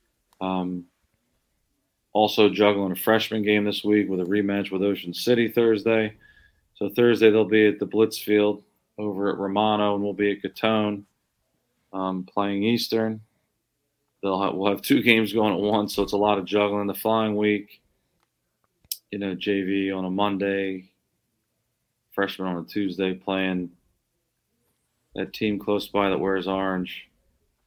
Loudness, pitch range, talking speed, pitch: -24 LUFS, 95-110 Hz, 150 wpm, 105 Hz